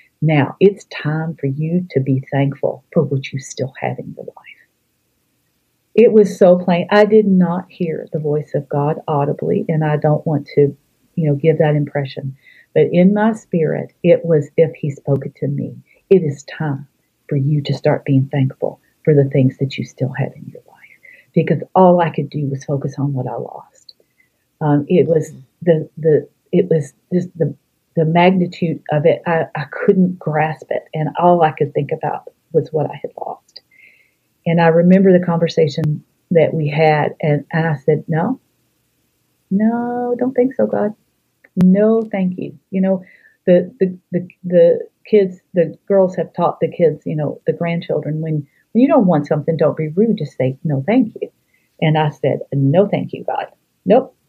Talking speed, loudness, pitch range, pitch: 190 wpm, -17 LUFS, 150-185 Hz, 160 Hz